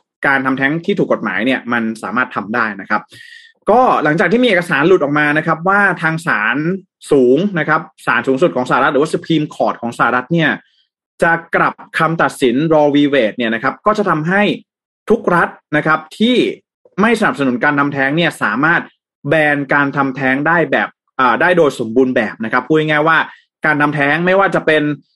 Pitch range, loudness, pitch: 140-180 Hz, -14 LUFS, 155 Hz